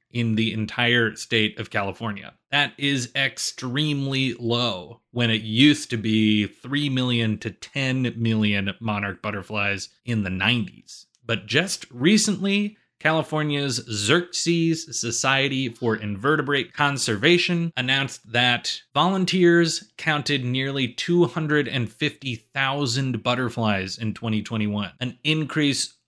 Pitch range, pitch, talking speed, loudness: 110-145 Hz, 125 Hz, 105 wpm, -23 LUFS